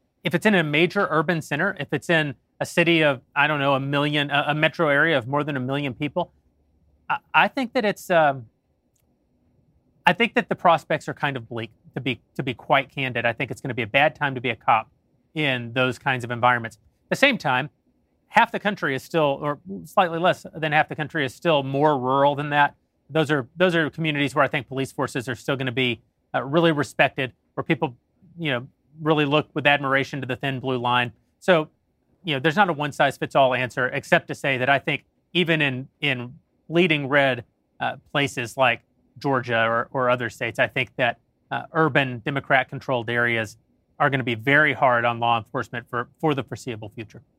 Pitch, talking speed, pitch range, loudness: 140 Hz, 215 wpm, 125-155 Hz, -22 LUFS